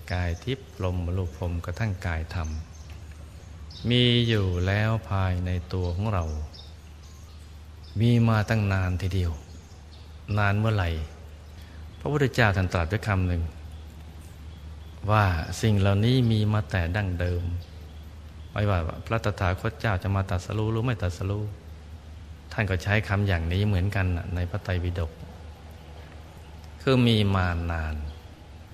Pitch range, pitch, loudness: 80-100 Hz, 90 Hz, -26 LUFS